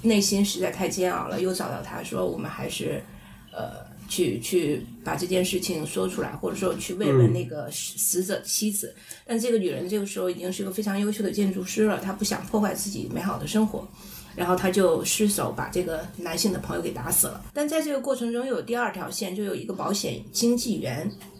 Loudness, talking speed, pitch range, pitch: -26 LUFS, 320 characters per minute, 180-215 Hz, 195 Hz